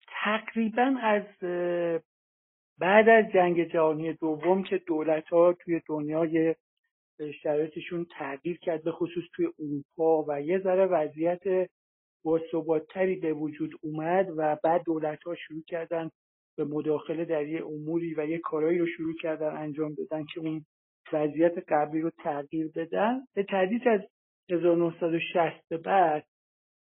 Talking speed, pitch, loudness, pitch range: 130 wpm, 165 Hz, -28 LUFS, 155-175 Hz